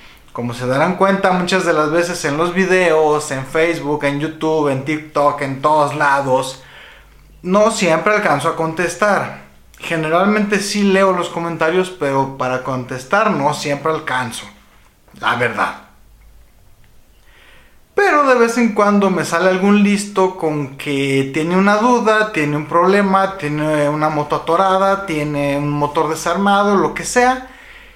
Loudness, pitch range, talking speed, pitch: -16 LUFS, 145-195 Hz, 140 wpm, 160 Hz